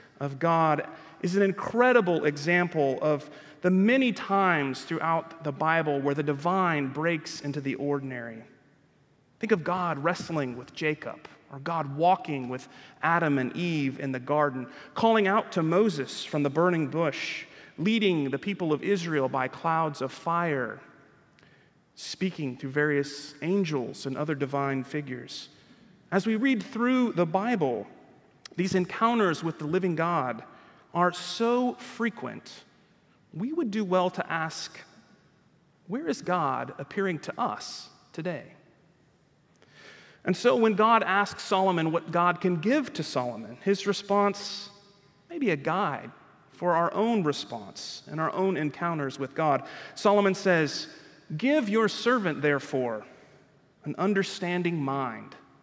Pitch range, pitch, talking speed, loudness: 145-195 Hz, 165 Hz, 135 wpm, -27 LUFS